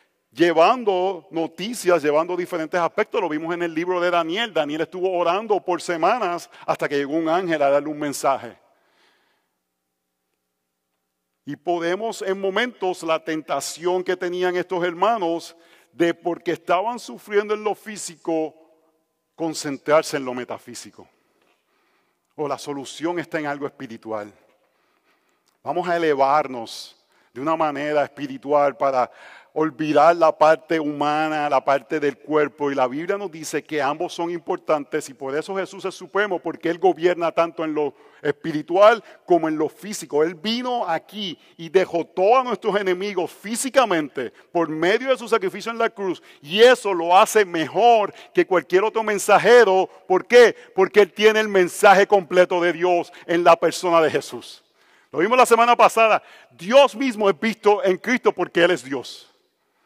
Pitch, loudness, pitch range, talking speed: 170 Hz, -20 LUFS, 150-195 Hz, 150 wpm